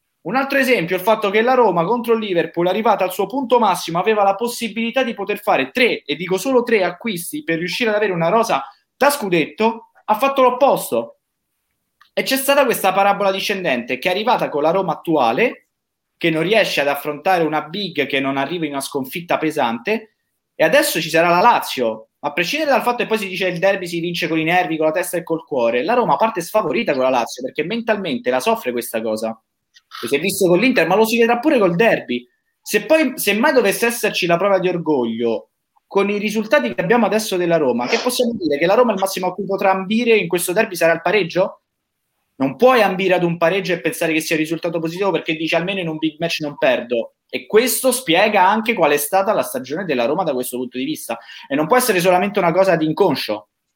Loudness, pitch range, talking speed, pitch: -18 LUFS, 165-225 Hz, 230 wpm, 190 Hz